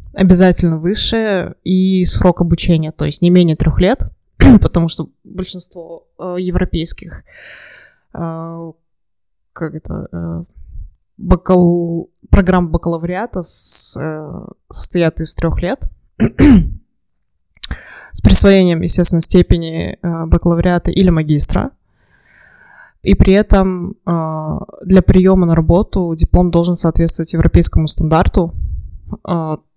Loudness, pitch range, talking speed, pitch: -13 LUFS, 160-180 Hz, 100 wpm, 170 Hz